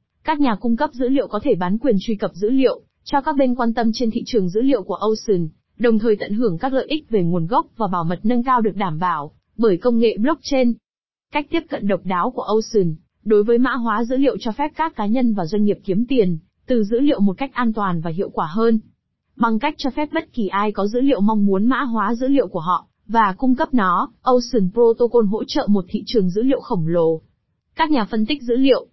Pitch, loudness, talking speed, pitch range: 230 Hz, -19 LUFS, 250 wpm, 200-255 Hz